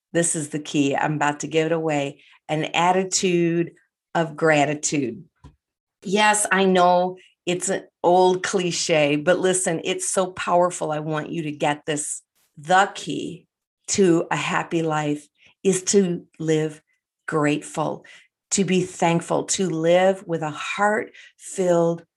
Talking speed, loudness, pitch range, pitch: 140 wpm, -22 LUFS, 155-185 Hz, 170 Hz